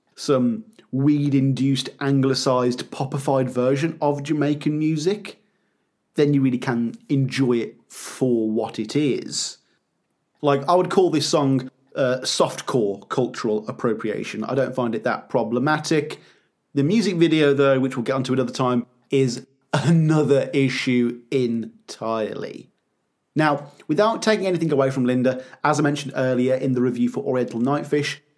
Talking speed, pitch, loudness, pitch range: 140 wpm, 135 Hz, -22 LUFS, 125-150 Hz